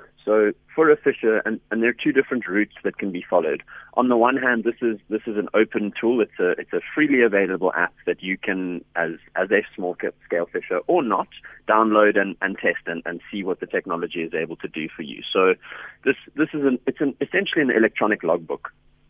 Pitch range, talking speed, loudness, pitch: 100-145 Hz, 225 wpm, -22 LUFS, 115 Hz